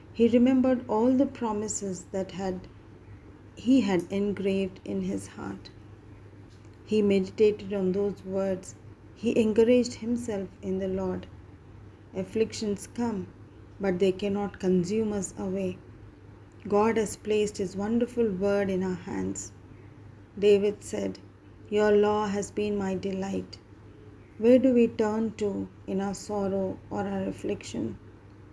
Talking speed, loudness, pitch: 125 wpm, -28 LUFS, 190 Hz